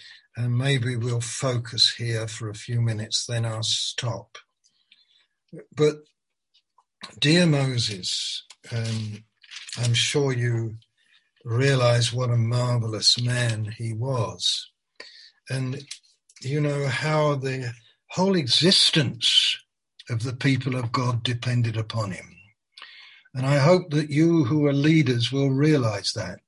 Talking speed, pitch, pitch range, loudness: 120 wpm, 125 Hz, 115-140 Hz, -23 LUFS